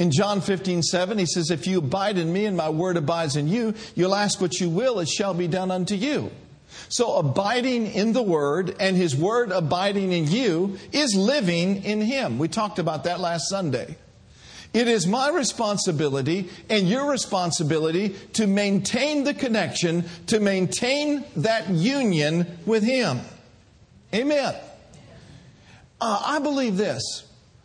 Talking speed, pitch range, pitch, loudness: 155 wpm, 175-225 Hz, 195 Hz, -23 LUFS